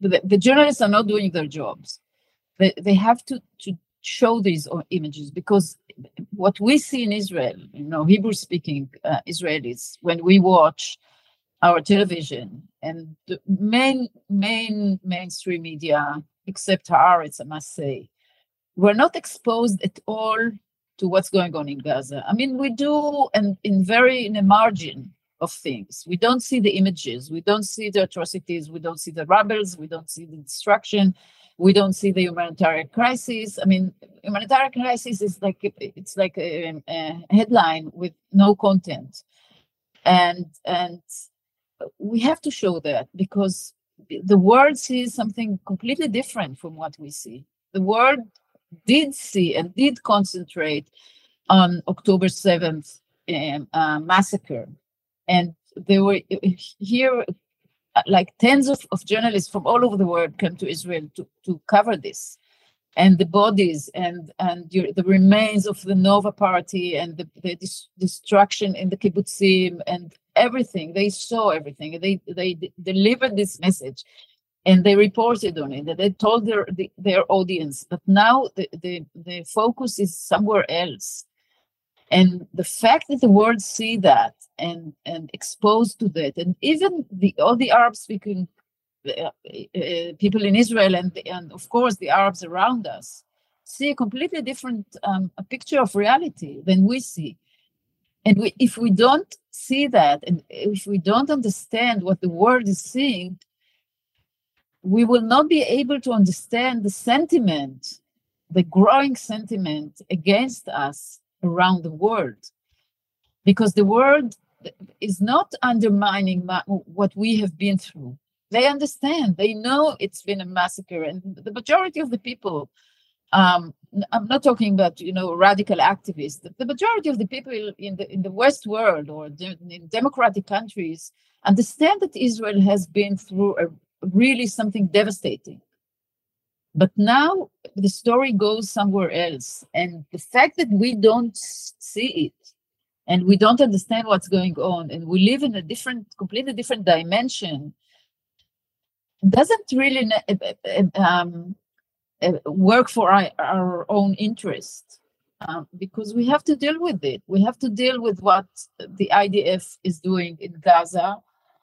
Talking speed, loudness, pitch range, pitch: 150 wpm, -20 LUFS, 175-225 Hz, 195 Hz